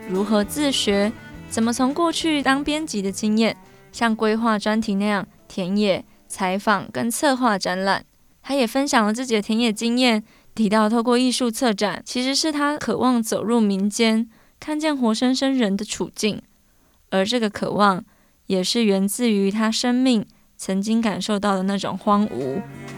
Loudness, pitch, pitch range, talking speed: -21 LUFS, 220 Hz, 205-245 Hz, 245 characters per minute